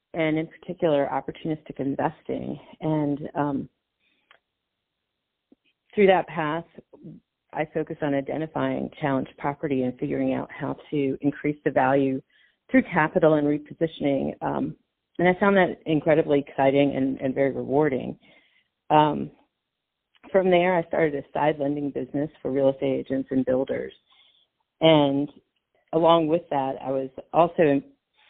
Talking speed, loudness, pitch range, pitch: 130 wpm, -24 LUFS, 140-160 Hz, 150 Hz